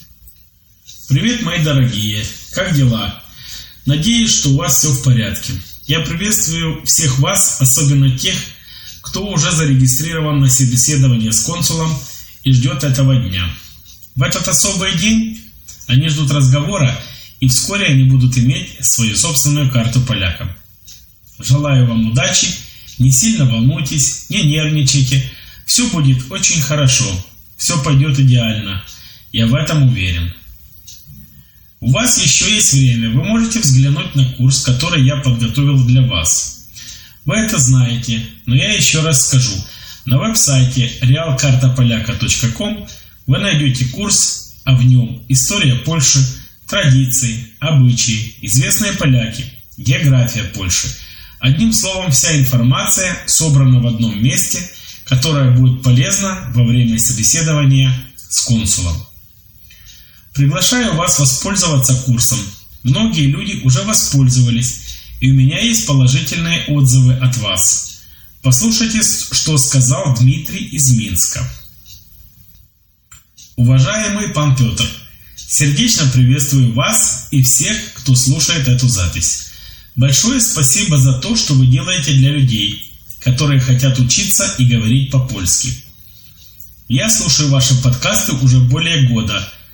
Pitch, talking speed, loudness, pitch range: 130 Hz, 120 wpm, -13 LUFS, 115-145 Hz